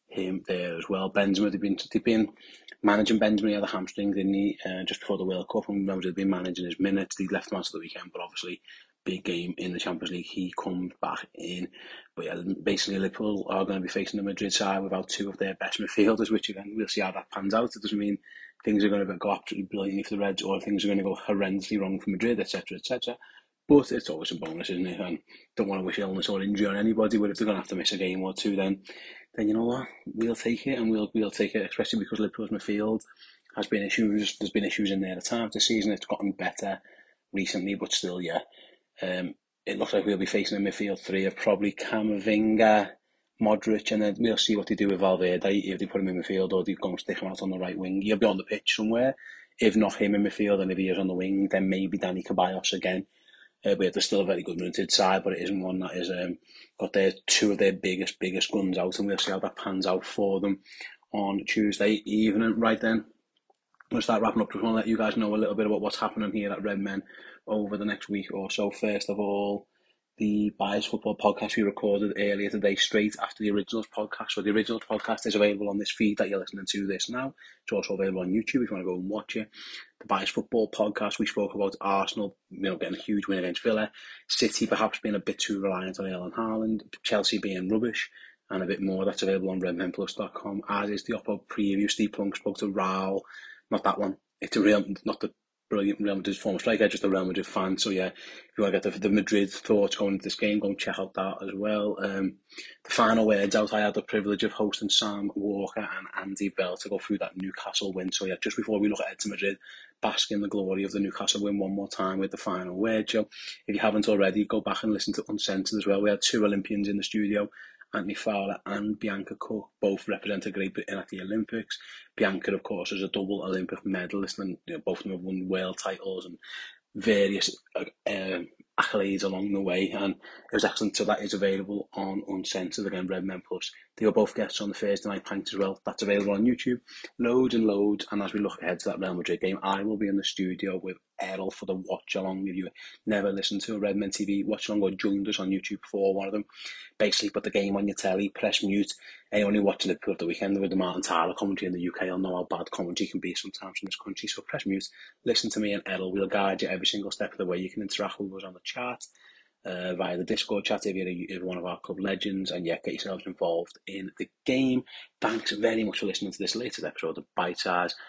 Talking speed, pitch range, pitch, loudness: 250 wpm, 95-105 Hz, 100 Hz, -29 LUFS